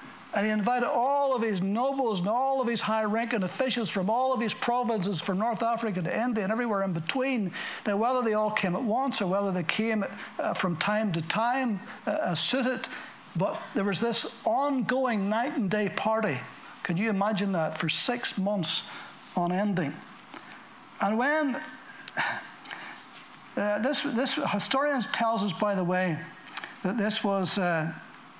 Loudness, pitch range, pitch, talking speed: -28 LUFS, 195-245 Hz, 215 Hz, 165 wpm